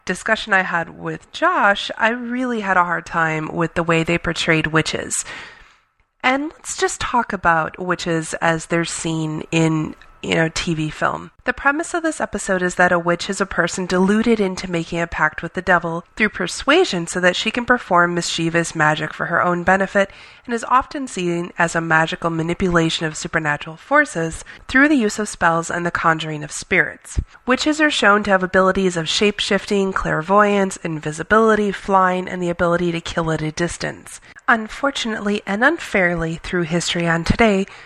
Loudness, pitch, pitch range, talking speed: -19 LUFS, 180 Hz, 165-210 Hz, 180 wpm